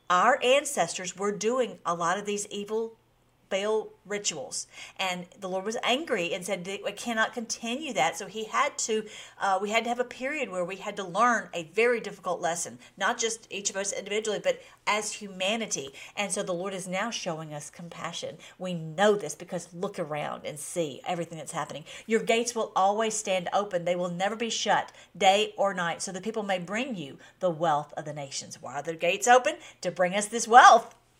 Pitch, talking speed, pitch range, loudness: 200 Hz, 205 wpm, 180-225 Hz, -28 LUFS